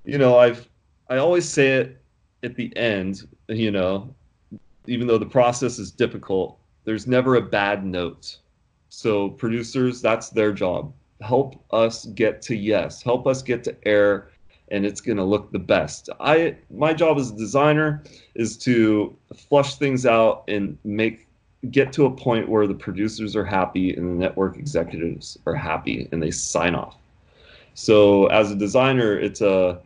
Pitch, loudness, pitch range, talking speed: 110 Hz, -21 LUFS, 100-125 Hz, 165 wpm